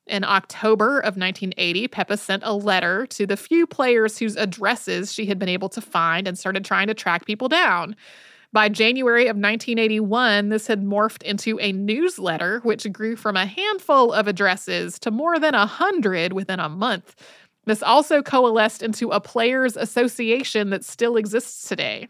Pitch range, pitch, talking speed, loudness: 200-235 Hz, 215 Hz, 175 wpm, -21 LUFS